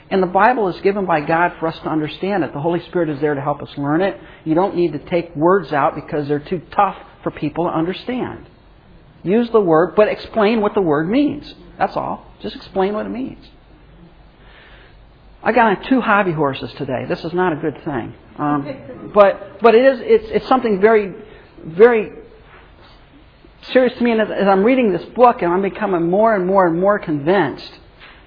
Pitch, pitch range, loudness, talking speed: 185 Hz, 160-215 Hz, -17 LUFS, 200 wpm